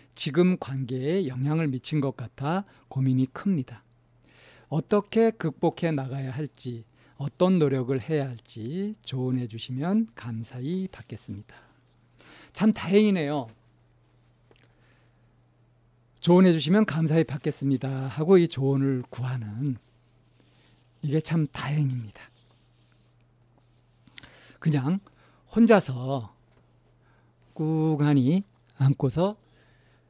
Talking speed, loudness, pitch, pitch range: 205 characters per minute, -26 LUFS, 135 Hz, 120-160 Hz